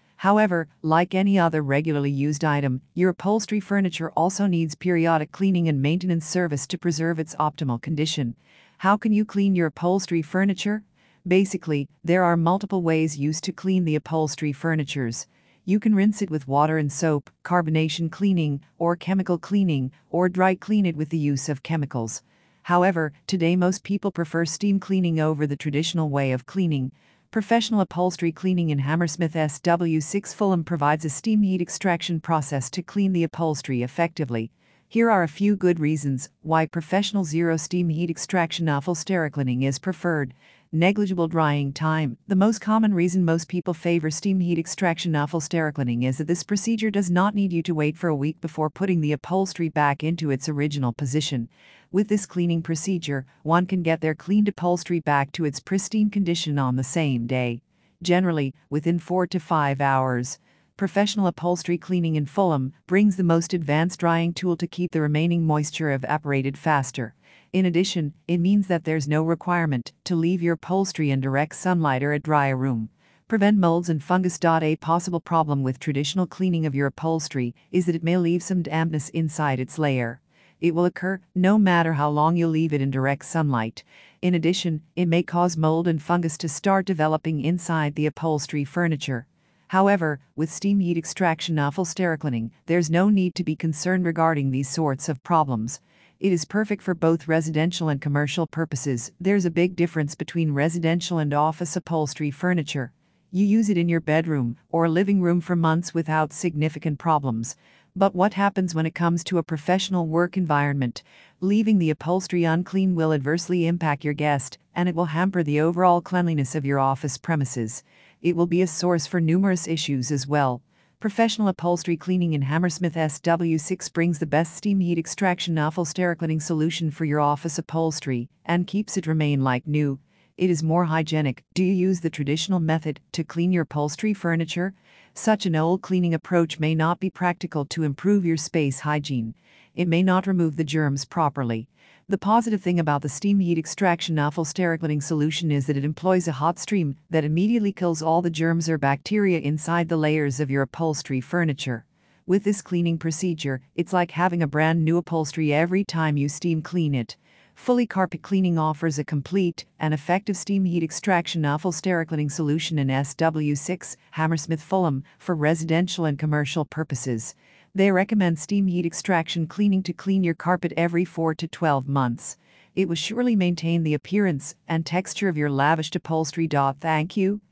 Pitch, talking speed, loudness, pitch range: 165 Hz, 175 wpm, -23 LUFS, 150-180 Hz